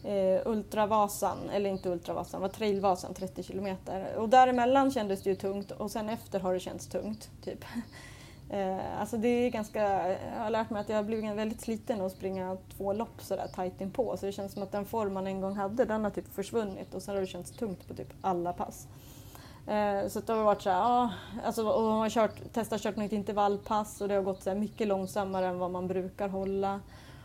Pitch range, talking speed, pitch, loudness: 190-220 Hz, 220 wpm, 200 Hz, -32 LUFS